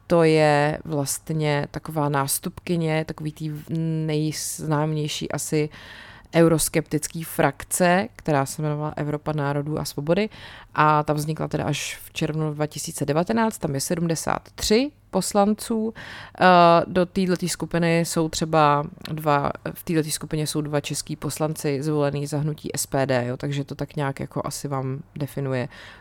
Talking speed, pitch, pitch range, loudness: 130 wpm, 155 Hz, 145-165 Hz, -23 LUFS